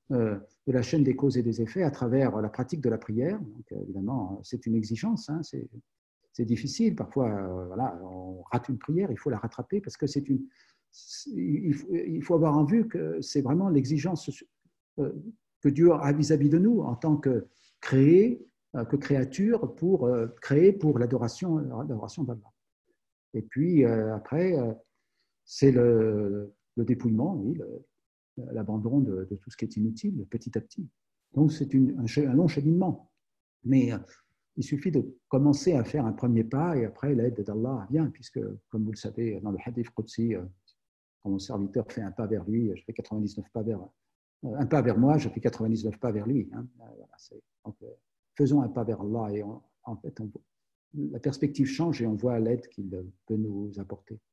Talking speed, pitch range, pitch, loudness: 200 wpm, 110-145 Hz, 125 Hz, -28 LUFS